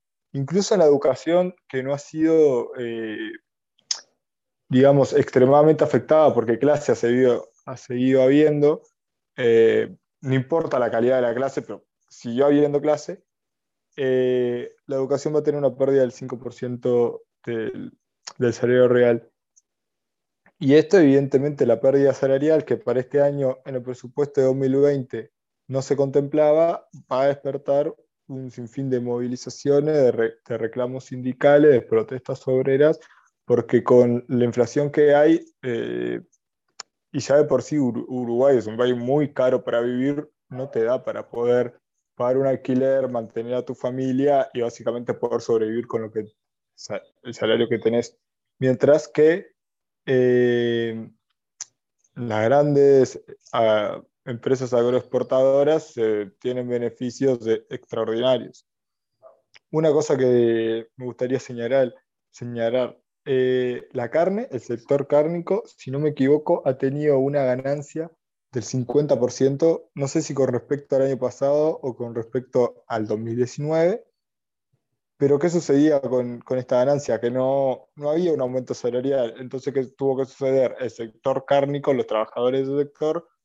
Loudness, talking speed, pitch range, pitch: -21 LUFS, 140 wpm, 125-145 Hz, 130 Hz